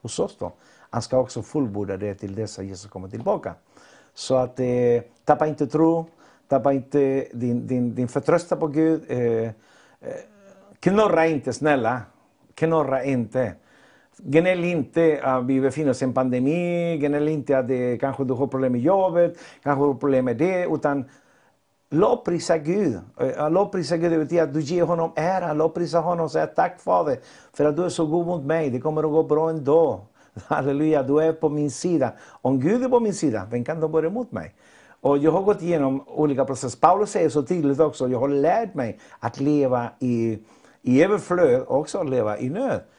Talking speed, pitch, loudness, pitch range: 190 wpm, 150 Hz, -22 LUFS, 130-165 Hz